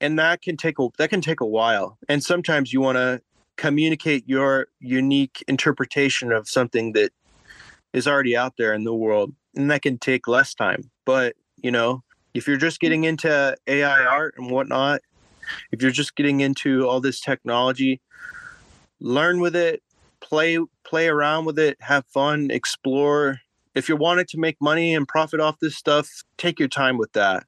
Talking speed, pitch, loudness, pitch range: 180 wpm, 145 Hz, -21 LUFS, 130-160 Hz